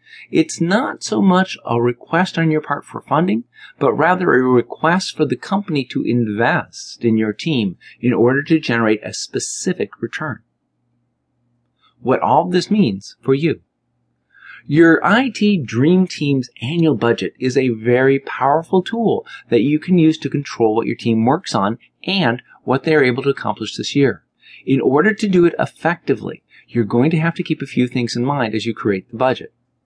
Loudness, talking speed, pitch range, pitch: -17 LUFS, 180 wpm, 115-165 Hz, 130 Hz